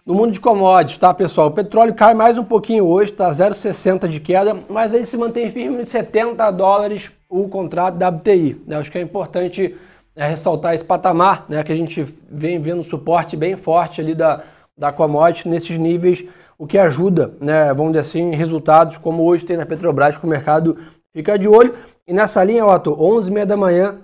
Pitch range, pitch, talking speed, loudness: 160-205 Hz, 180 Hz, 200 wpm, -16 LUFS